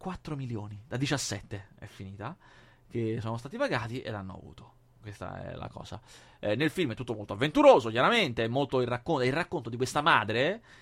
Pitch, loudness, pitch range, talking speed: 125 Hz, -29 LUFS, 105-140 Hz, 195 wpm